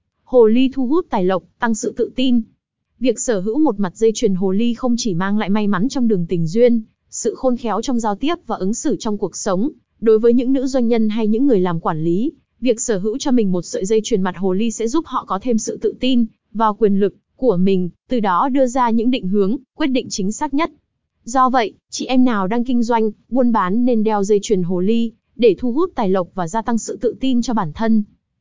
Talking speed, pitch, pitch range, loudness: 255 wpm, 230 Hz, 205-255 Hz, -18 LUFS